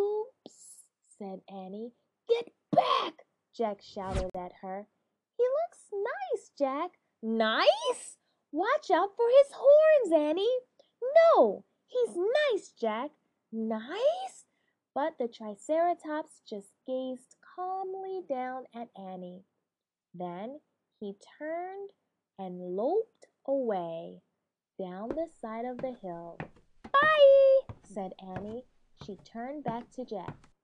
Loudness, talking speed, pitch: -29 LUFS, 105 wpm, 260 Hz